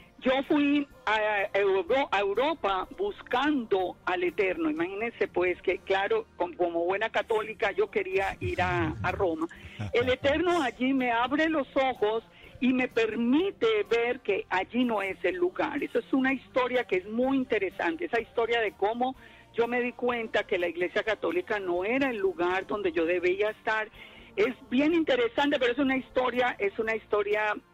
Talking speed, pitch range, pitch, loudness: 160 wpm, 205-280 Hz, 240 Hz, -28 LUFS